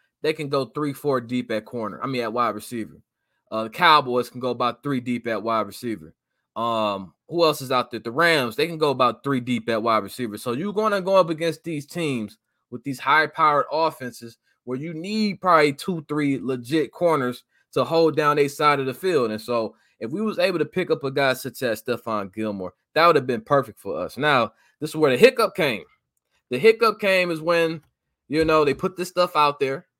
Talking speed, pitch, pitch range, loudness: 220 wpm, 135 Hz, 120-160 Hz, -22 LUFS